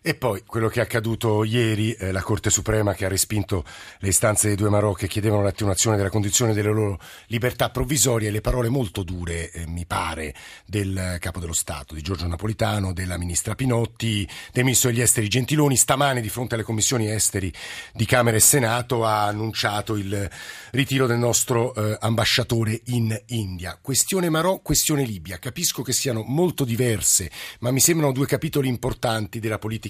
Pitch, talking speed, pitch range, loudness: 110 Hz, 175 wpm, 100-125 Hz, -22 LUFS